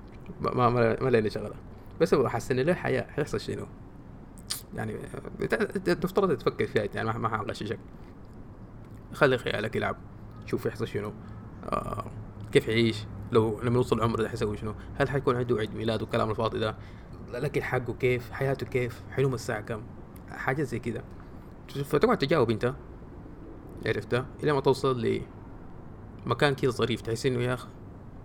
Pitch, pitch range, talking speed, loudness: 115 Hz, 105-125 Hz, 145 wpm, -29 LUFS